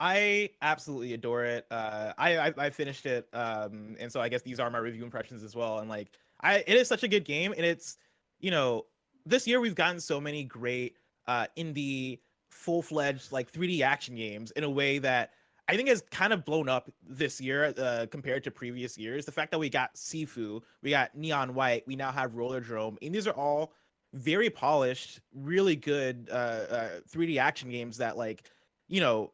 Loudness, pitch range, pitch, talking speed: -31 LUFS, 120-160 Hz, 135 Hz, 200 wpm